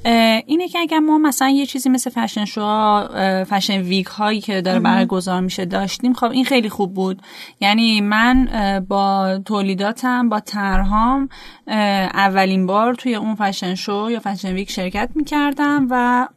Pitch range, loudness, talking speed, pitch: 195-250 Hz, -18 LUFS, 150 wpm, 210 Hz